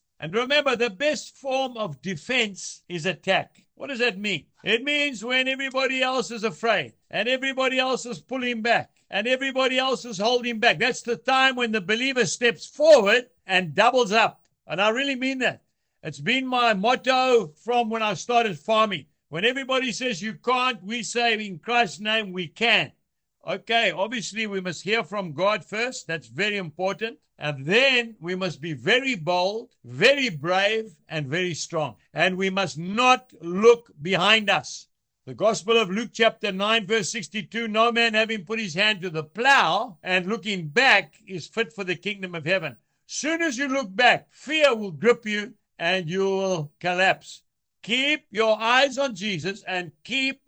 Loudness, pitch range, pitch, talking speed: -23 LUFS, 185-245 Hz, 220 Hz, 175 wpm